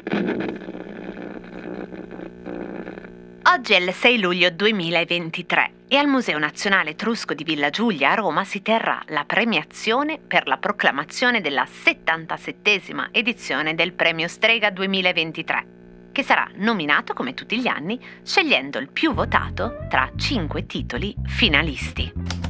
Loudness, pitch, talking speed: -20 LUFS, 170 Hz, 120 wpm